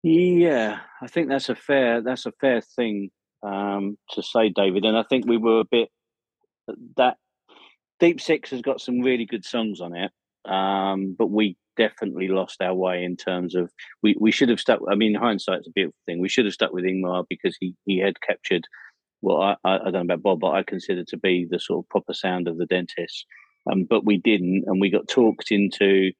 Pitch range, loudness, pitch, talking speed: 95-120 Hz, -23 LUFS, 100 Hz, 215 wpm